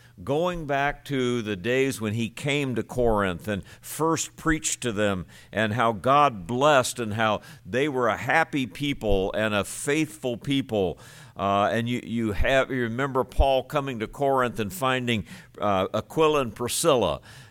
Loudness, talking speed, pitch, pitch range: -25 LUFS, 160 wpm, 120 Hz, 110-140 Hz